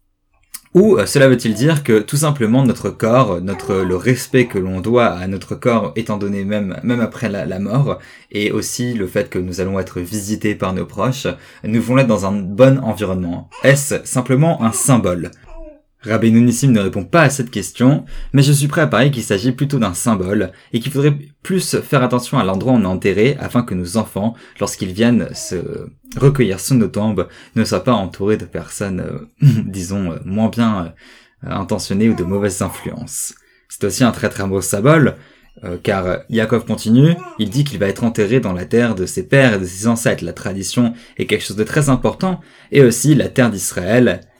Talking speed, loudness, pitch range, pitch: 200 wpm, -16 LUFS, 100-130 Hz, 115 Hz